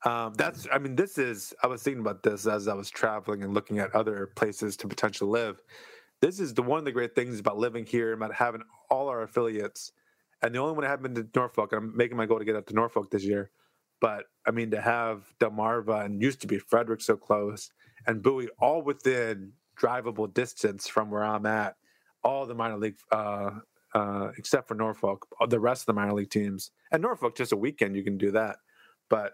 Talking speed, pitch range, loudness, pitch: 225 wpm, 105-120 Hz, -29 LUFS, 110 Hz